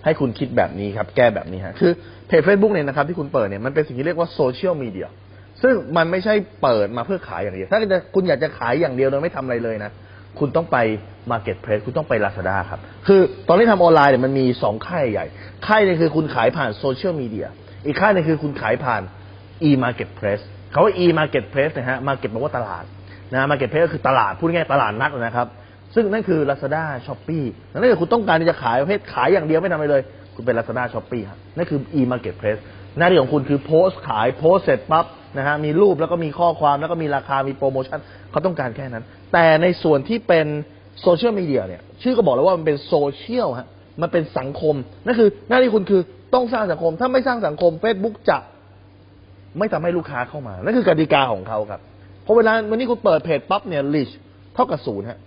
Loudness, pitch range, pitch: -19 LUFS, 110-170 Hz, 145 Hz